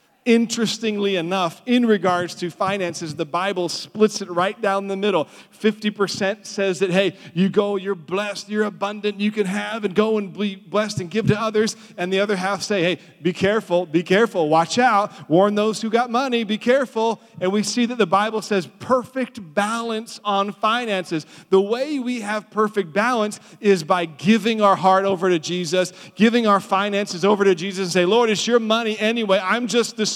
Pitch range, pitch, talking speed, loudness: 190-220 Hz, 205 Hz, 190 wpm, -20 LUFS